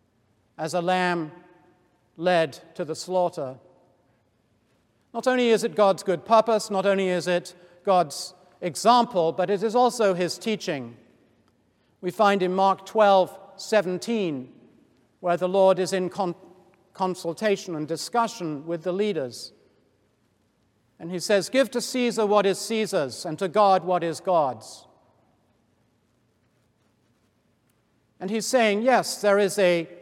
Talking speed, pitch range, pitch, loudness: 130 wpm, 140-200 Hz, 180 Hz, -24 LUFS